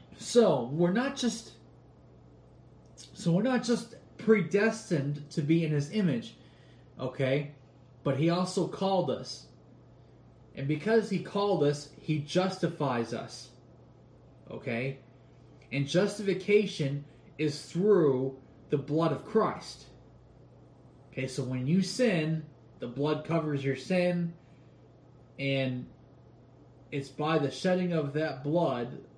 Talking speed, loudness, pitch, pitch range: 115 wpm, -30 LUFS, 155 Hz, 135-185 Hz